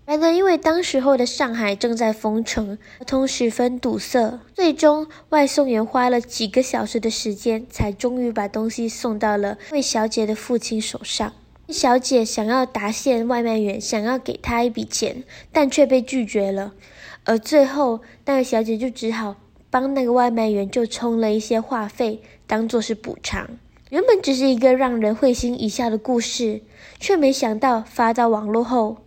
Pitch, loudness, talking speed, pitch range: 240 Hz, -20 LUFS, 260 characters per minute, 220-260 Hz